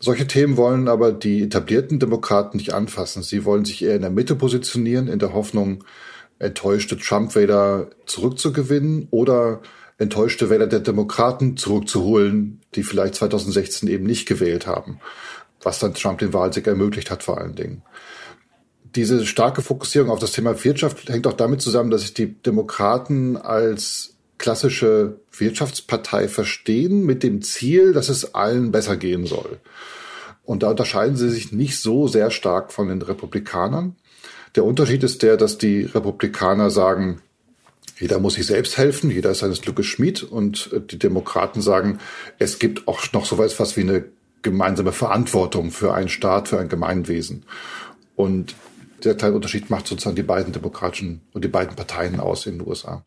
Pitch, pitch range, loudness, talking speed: 110 Hz, 100-125 Hz, -20 LUFS, 160 wpm